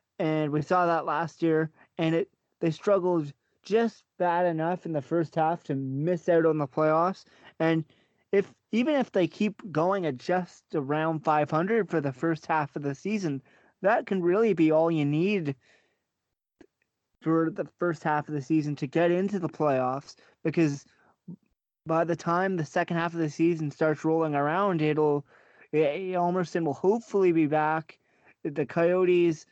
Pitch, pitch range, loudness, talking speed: 165 Hz, 155-180 Hz, -27 LUFS, 165 wpm